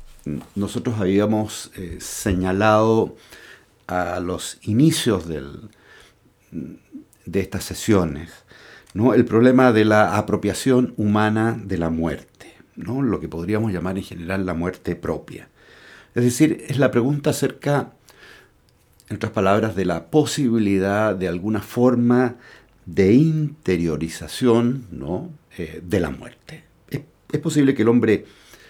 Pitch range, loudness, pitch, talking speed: 95-120 Hz, -20 LUFS, 105 Hz, 125 wpm